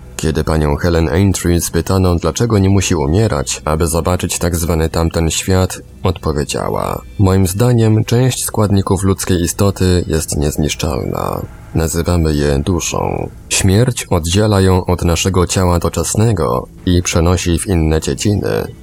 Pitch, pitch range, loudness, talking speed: 90 Hz, 80-95 Hz, -15 LUFS, 125 wpm